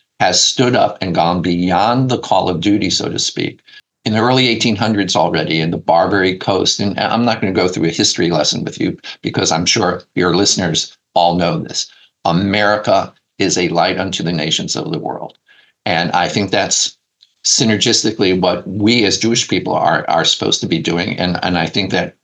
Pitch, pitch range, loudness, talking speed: 100 Hz, 90-115 Hz, -15 LUFS, 195 wpm